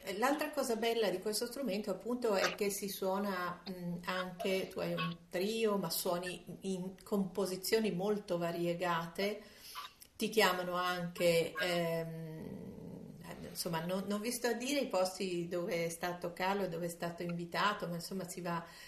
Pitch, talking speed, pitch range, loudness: 185 Hz, 155 wpm, 175-210 Hz, -36 LUFS